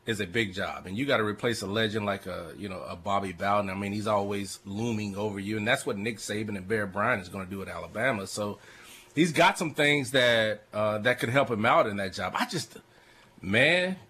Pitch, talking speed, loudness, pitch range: 105 Hz, 245 wpm, -28 LUFS, 100-120 Hz